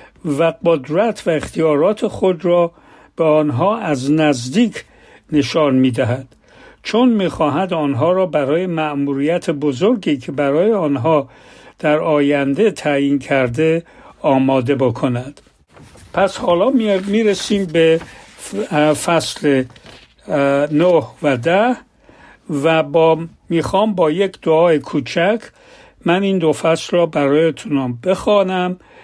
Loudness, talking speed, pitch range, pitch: -16 LUFS, 110 wpm, 145-190 Hz, 160 Hz